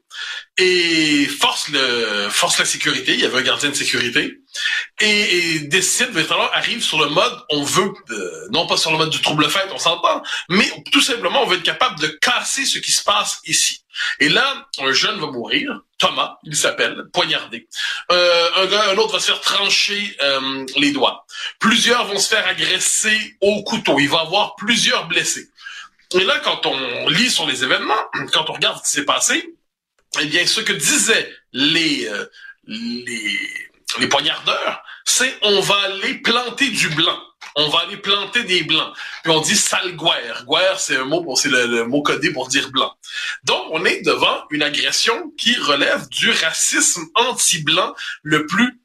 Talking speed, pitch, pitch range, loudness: 185 wpm, 215 Hz, 175-285 Hz, -16 LUFS